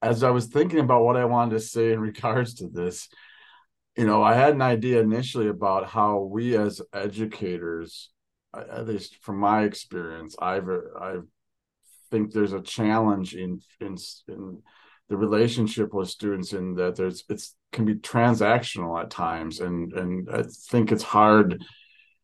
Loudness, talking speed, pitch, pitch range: -24 LUFS, 160 wpm, 105 Hz, 95-115 Hz